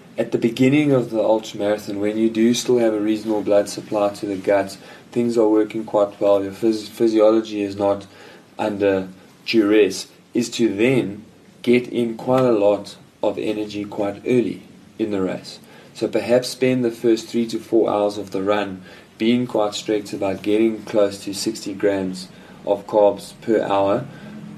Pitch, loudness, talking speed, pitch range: 105 Hz, -20 LUFS, 170 wpm, 100-115 Hz